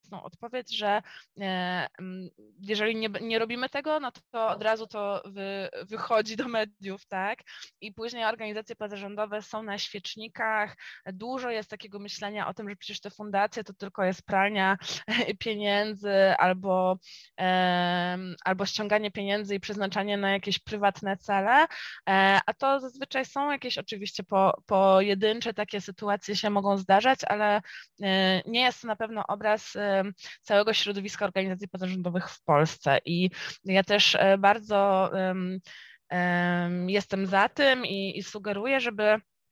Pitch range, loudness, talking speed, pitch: 195-215 Hz, -27 LUFS, 135 wpm, 205 Hz